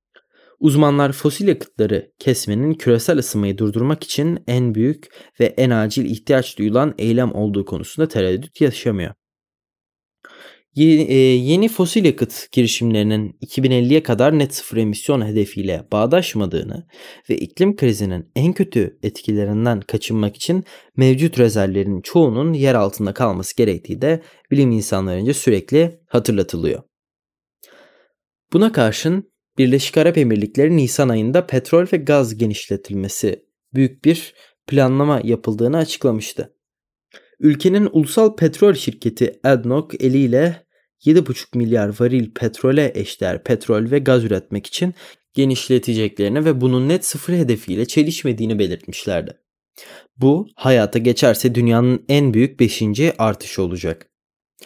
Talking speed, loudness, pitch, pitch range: 110 wpm, -17 LUFS, 130 Hz, 110-150 Hz